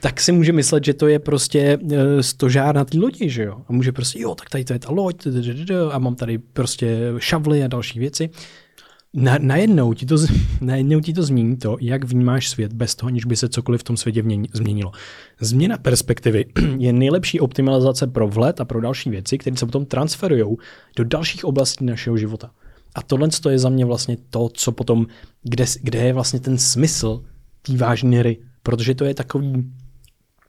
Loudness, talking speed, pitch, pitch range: -19 LUFS, 195 wpm, 130 Hz, 120-140 Hz